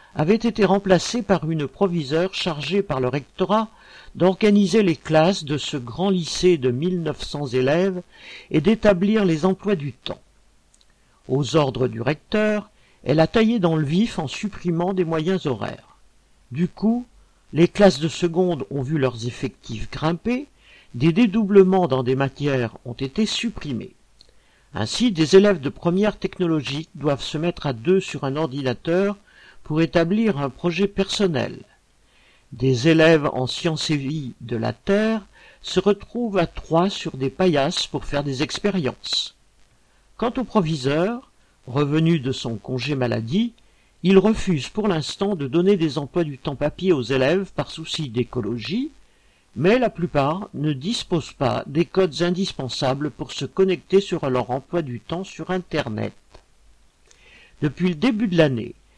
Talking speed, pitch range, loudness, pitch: 150 wpm, 140-195 Hz, -22 LUFS, 165 Hz